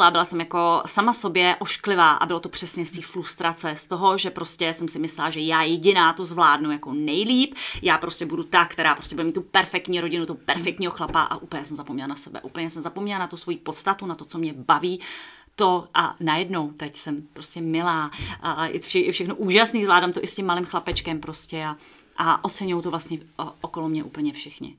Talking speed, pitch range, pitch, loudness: 220 wpm, 160-185 Hz, 170 Hz, -23 LUFS